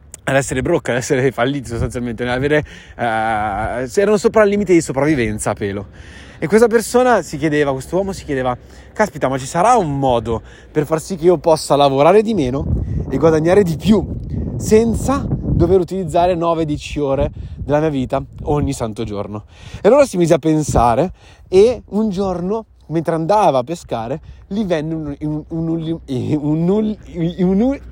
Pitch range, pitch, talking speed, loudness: 130-185 Hz, 155 Hz, 170 wpm, -17 LUFS